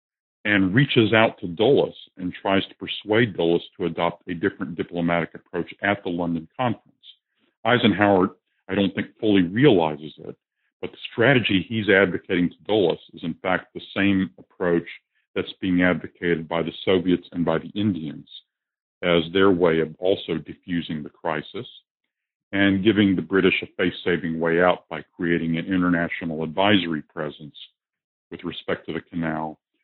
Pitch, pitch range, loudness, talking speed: 90 Hz, 85-100 Hz, -22 LUFS, 155 wpm